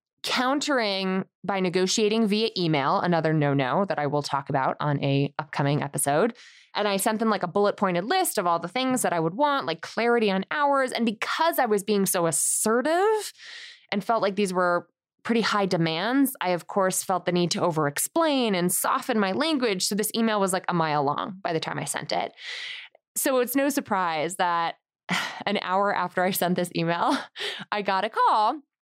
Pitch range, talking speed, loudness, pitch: 170-240 Hz, 195 wpm, -25 LUFS, 195 Hz